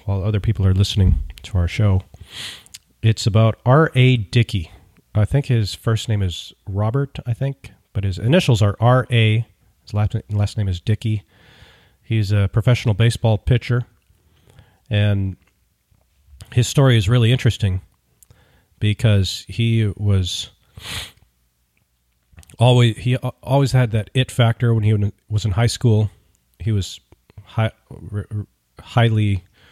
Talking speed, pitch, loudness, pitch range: 130 wpm, 105 Hz, -19 LUFS, 95-115 Hz